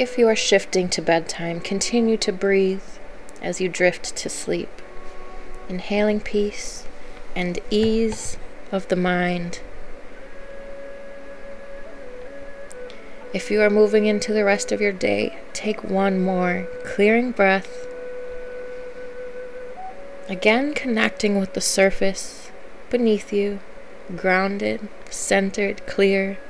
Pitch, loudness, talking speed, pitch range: 210 Hz, -21 LUFS, 105 wpm, 195-275 Hz